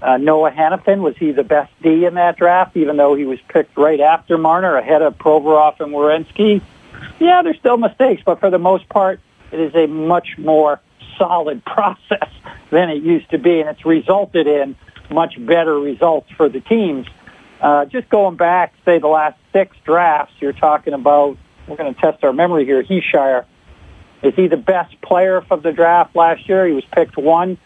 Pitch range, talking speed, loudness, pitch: 150-180 Hz, 195 wpm, -15 LUFS, 160 Hz